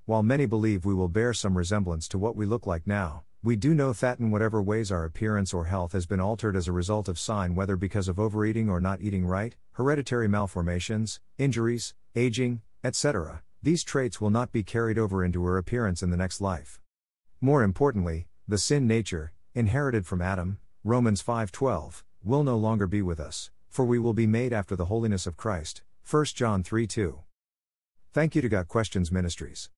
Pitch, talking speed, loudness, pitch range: 105 Hz, 195 wpm, -28 LUFS, 90-115 Hz